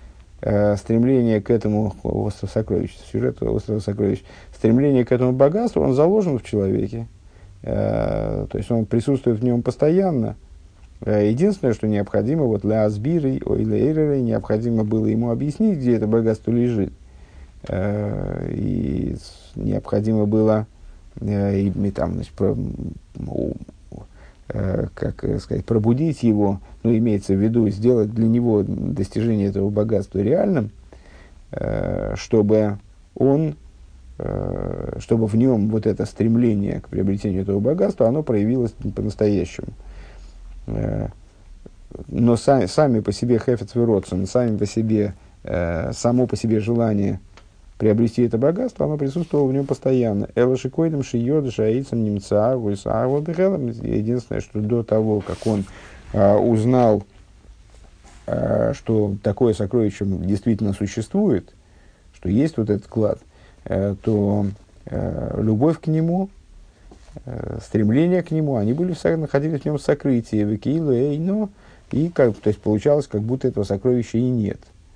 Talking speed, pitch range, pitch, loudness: 120 wpm, 100-125 Hz, 110 Hz, -21 LUFS